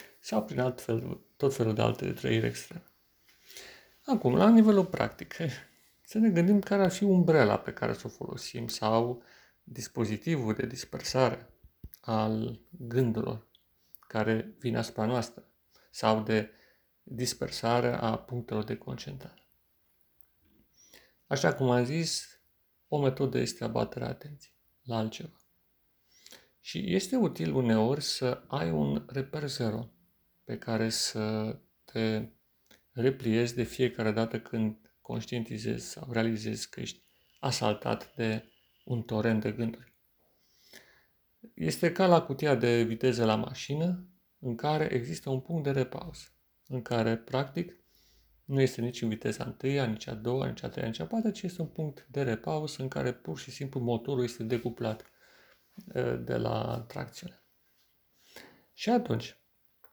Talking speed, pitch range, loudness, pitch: 135 wpm, 110-140 Hz, -31 LUFS, 120 Hz